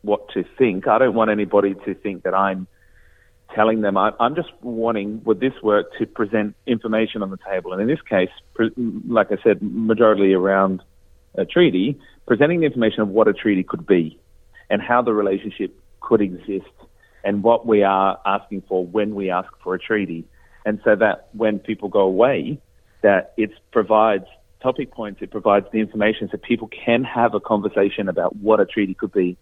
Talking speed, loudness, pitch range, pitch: 190 wpm, -20 LUFS, 95-115 Hz, 105 Hz